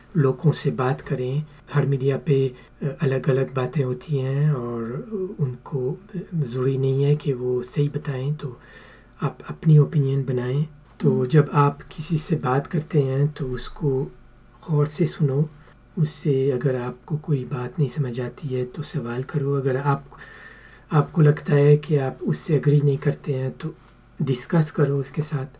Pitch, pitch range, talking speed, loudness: 140 Hz, 130-150 Hz, 160 wpm, -23 LUFS